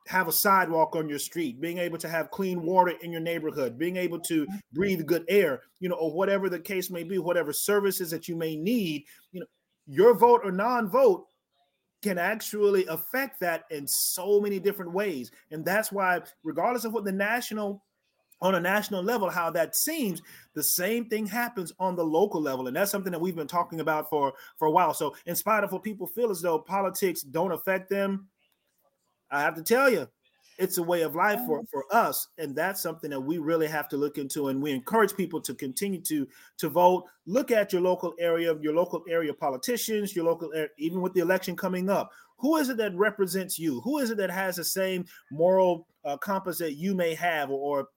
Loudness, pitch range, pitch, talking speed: -27 LUFS, 160-200 Hz, 180 Hz, 215 wpm